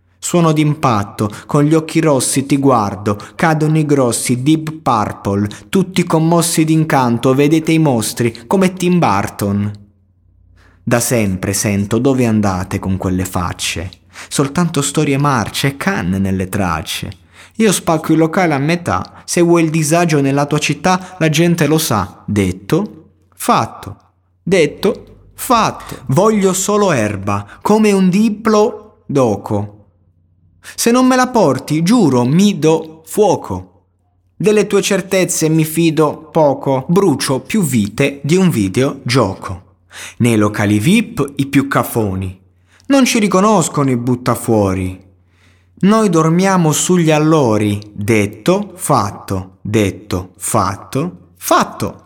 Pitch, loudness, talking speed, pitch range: 135 Hz, -14 LUFS, 120 wpm, 100-165 Hz